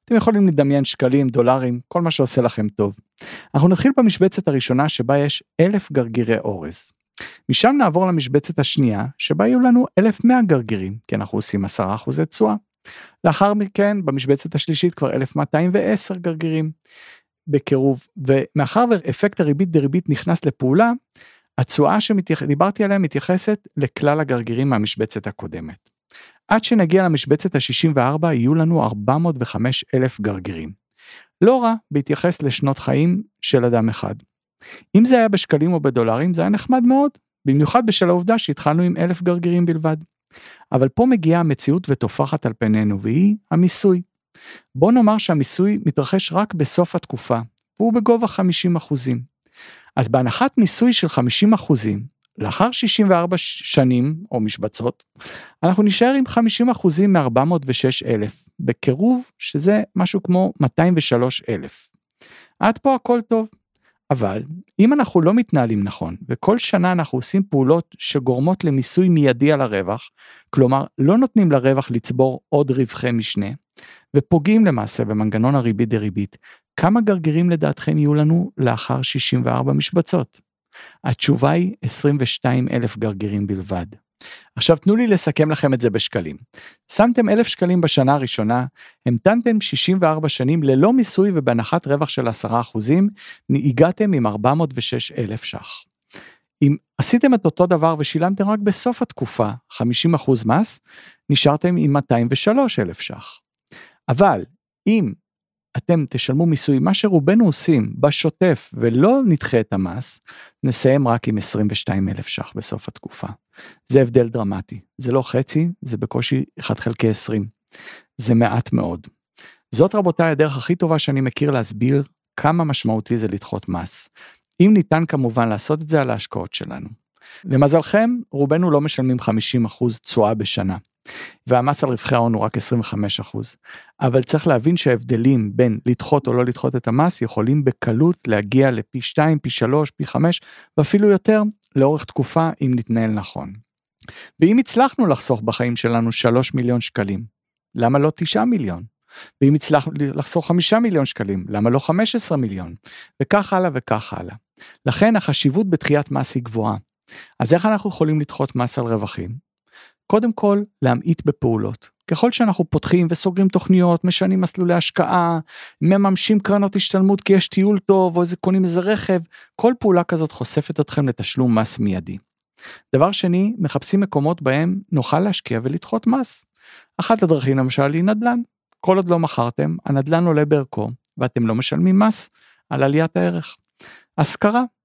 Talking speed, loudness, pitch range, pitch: 140 wpm, -18 LUFS, 125-185 Hz, 150 Hz